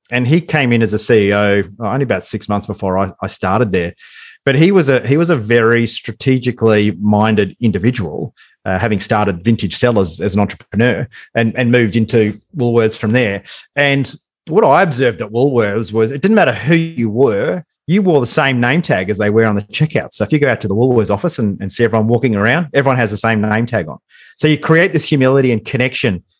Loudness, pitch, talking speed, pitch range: -14 LUFS, 115 Hz, 220 wpm, 105-135 Hz